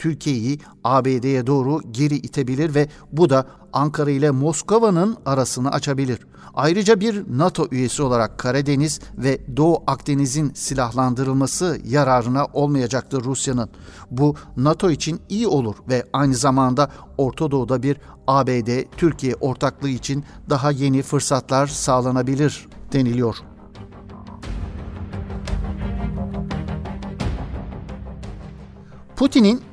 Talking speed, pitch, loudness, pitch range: 95 wpm, 135 Hz, -20 LUFS, 125-145 Hz